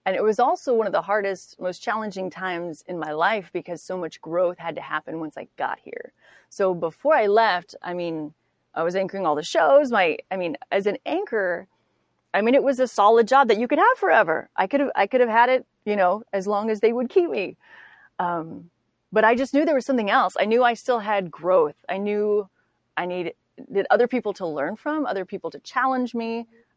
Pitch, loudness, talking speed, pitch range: 210 Hz, -23 LUFS, 225 wpm, 180-250 Hz